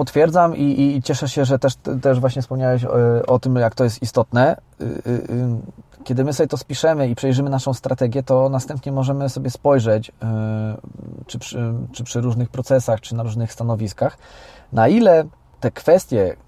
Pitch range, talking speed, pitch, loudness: 120-140 Hz, 180 wpm, 130 Hz, -19 LUFS